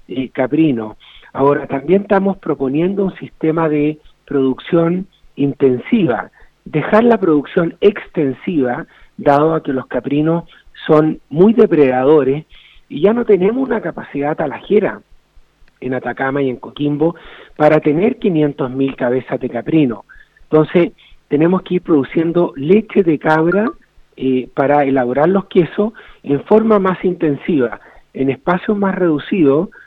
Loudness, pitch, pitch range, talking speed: -15 LUFS, 155 Hz, 140-185 Hz, 125 wpm